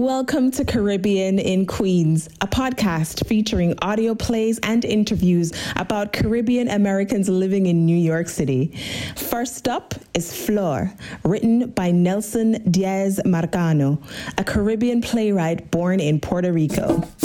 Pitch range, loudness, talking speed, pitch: 170-225 Hz, -20 LUFS, 125 wpm, 195 Hz